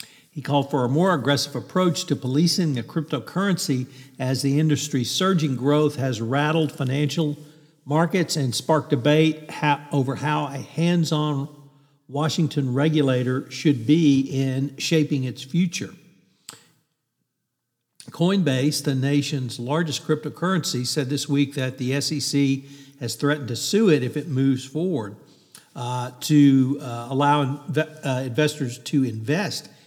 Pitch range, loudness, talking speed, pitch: 135-155 Hz, -23 LUFS, 130 wpm, 145 Hz